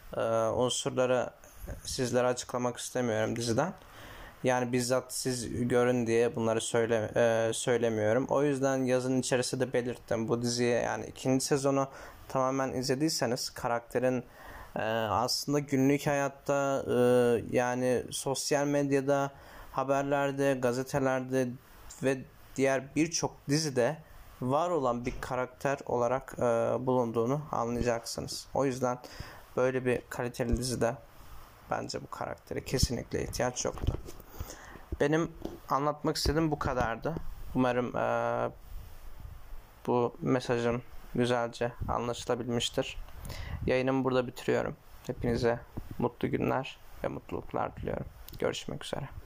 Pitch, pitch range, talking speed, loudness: 125 Hz, 120-135 Hz, 100 wpm, -31 LUFS